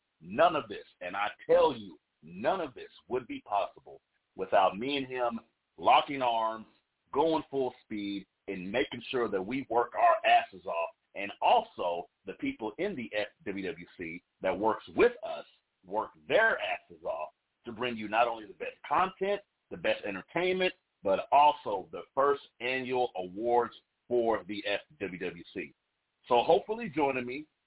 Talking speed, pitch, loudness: 150 wpm, 145 Hz, -31 LUFS